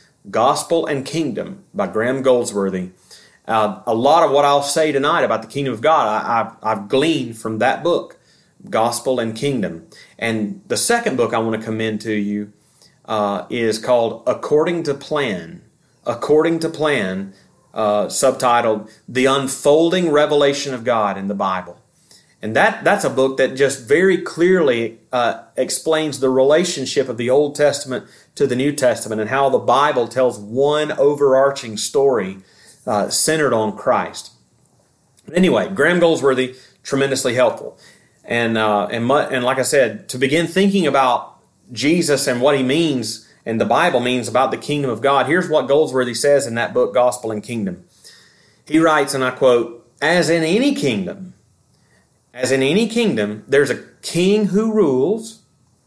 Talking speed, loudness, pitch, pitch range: 160 wpm, -17 LUFS, 135 Hz, 115-155 Hz